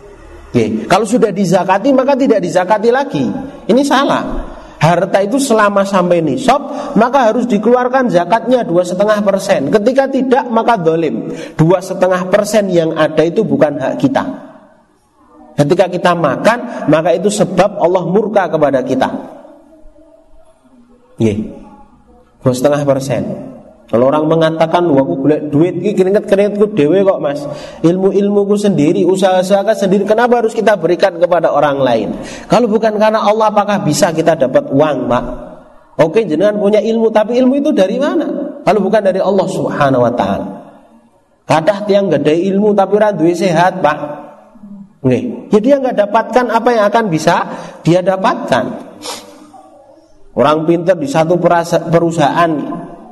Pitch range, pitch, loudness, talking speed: 175-245 Hz, 205 Hz, -12 LUFS, 140 wpm